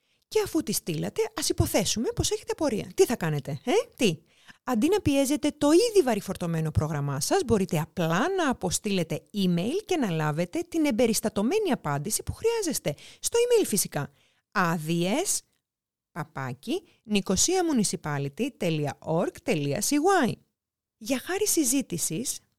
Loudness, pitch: -26 LUFS, 225 Hz